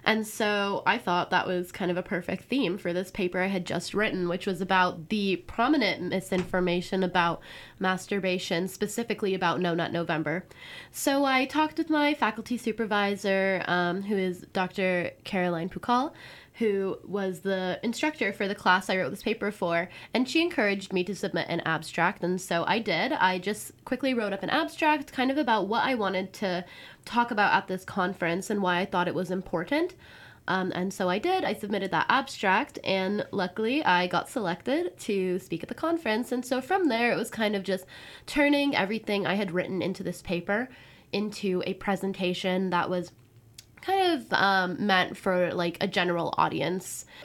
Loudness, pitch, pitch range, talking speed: -28 LUFS, 190 Hz, 180-220 Hz, 185 wpm